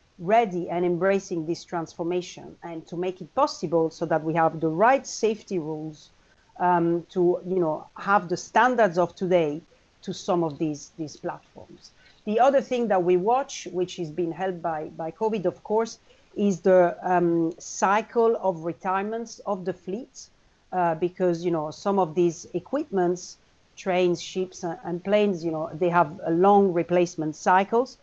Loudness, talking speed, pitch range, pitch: -25 LUFS, 165 wpm, 170-200 Hz, 180 Hz